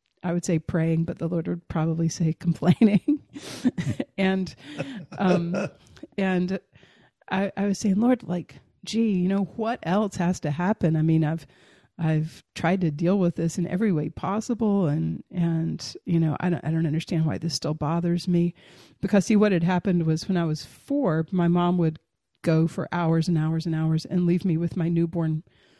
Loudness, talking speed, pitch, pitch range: -25 LUFS, 190 wpm, 170 Hz, 160-190 Hz